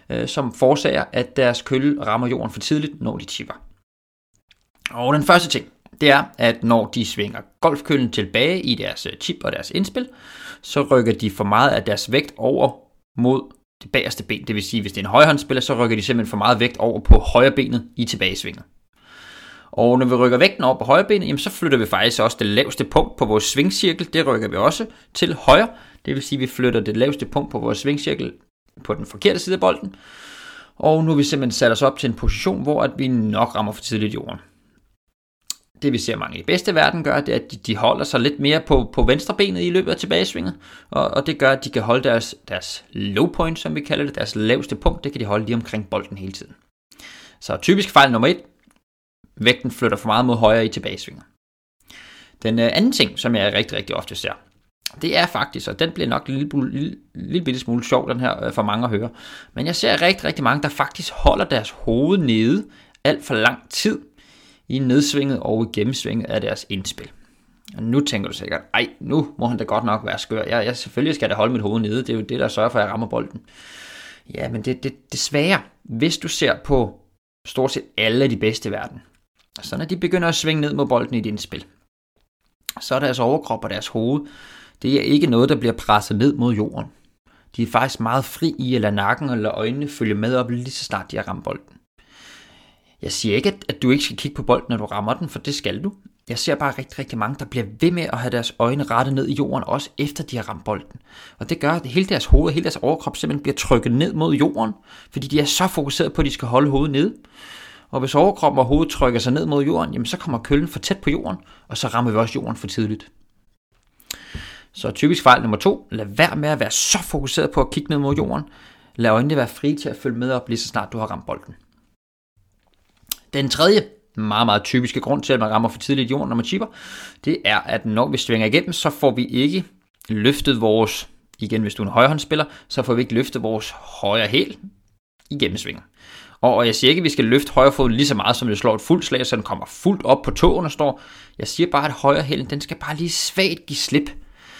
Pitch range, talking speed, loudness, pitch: 110-145 Hz, 235 wpm, -20 LUFS, 130 Hz